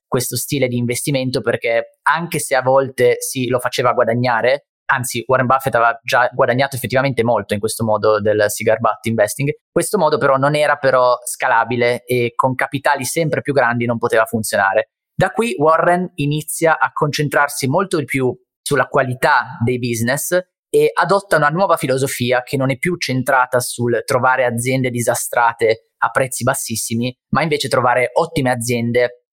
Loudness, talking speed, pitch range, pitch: -17 LUFS, 160 wpm, 120-150 Hz, 130 Hz